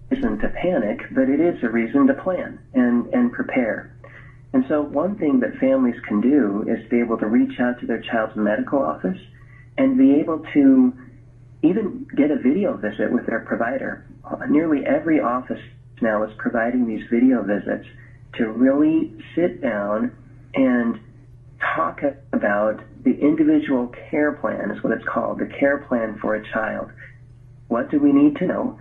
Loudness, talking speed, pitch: -21 LUFS, 165 wpm, 130 Hz